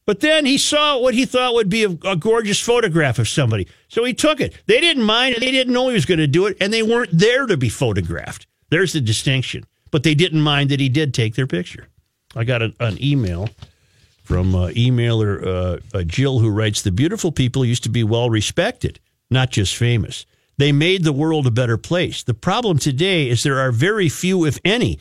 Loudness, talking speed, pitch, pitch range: -17 LUFS, 225 wpm, 145 Hz, 115-195 Hz